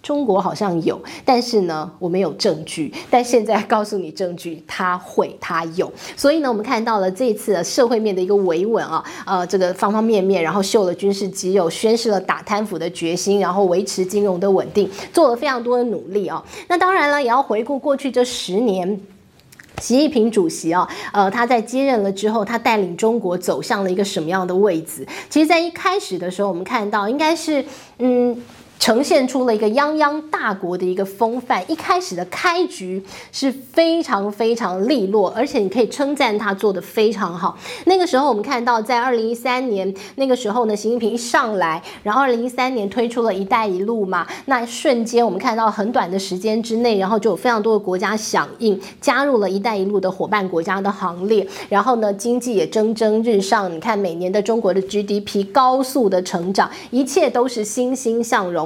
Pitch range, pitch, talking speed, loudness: 195-250 Hz, 220 Hz, 310 characters per minute, -19 LUFS